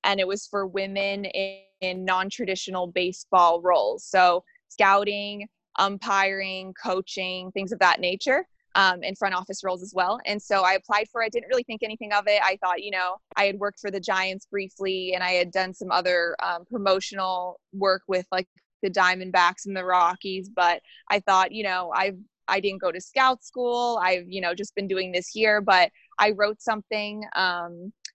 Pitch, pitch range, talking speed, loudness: 195 Hz, 185-205 Hz, 190 wpm, -24 LUFS